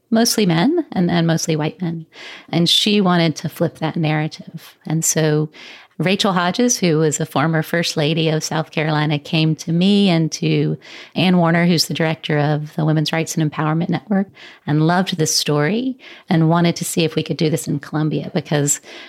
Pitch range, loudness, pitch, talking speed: 155-175 Hz, -18 LUFS, 160 Hz, 190 wpm